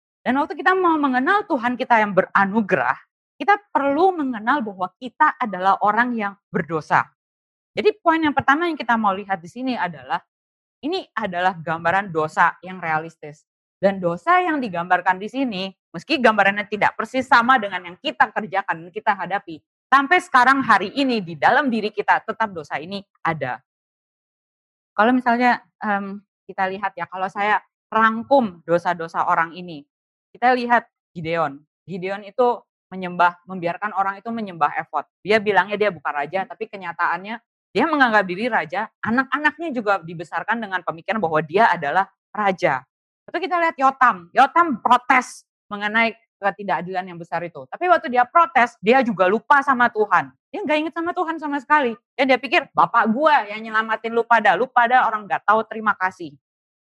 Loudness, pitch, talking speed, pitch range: -20 LUFS, 215 Hz, 160 wpm, 185-260 Hz